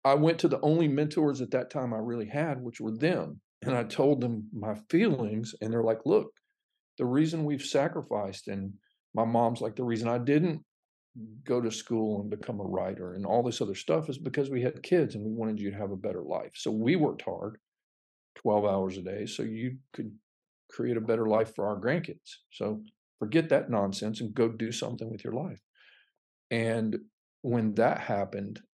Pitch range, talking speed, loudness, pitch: 110-140 Hz, 200 wpm, -30 LUFS, 115 Hz